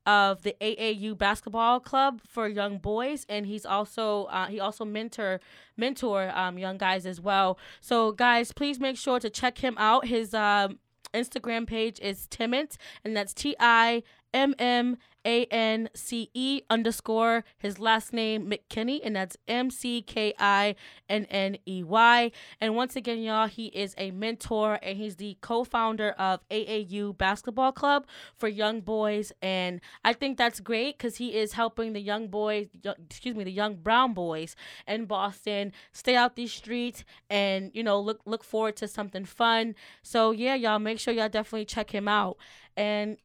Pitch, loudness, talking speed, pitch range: 220 Hz, -28 LUFS, 175 wpm, 205-235 Hz